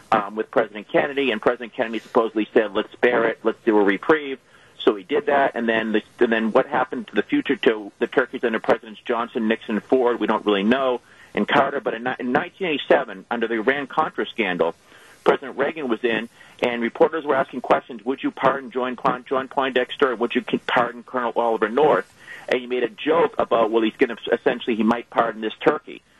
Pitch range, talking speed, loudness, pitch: 110-130 Hz, 205 wpm, -22 LUFS, 120 Hz